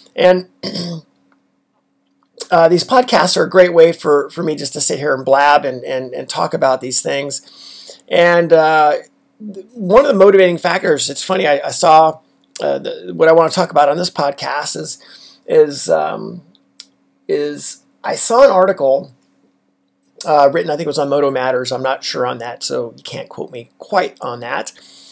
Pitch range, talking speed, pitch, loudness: 140-185 Hz, 185 wpm, 160 Hz, -13 LUFS